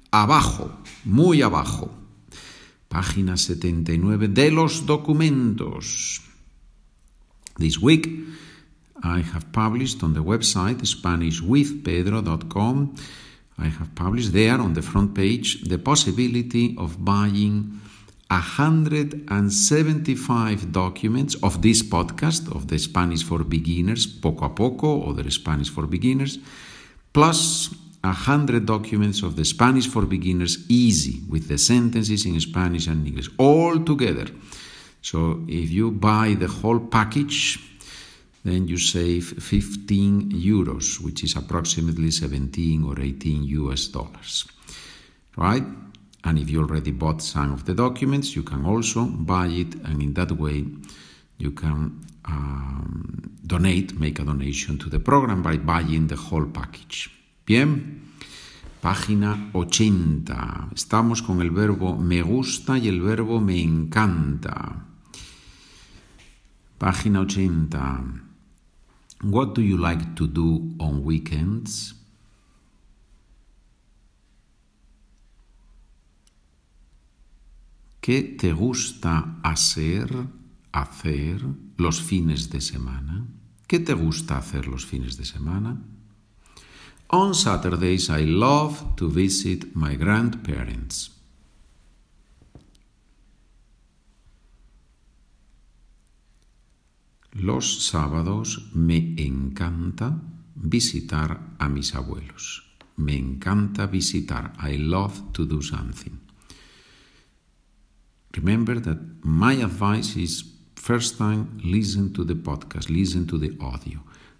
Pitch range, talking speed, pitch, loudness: 80-110 Hz, 105 wpm, 90 Hz, -23 LUFS